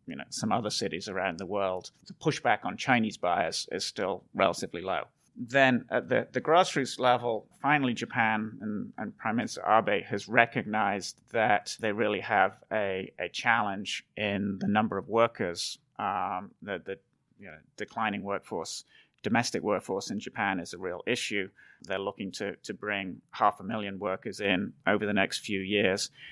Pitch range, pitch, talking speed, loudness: 100-115 Hz, 105 Hz, 170 wpm, -30 LUFS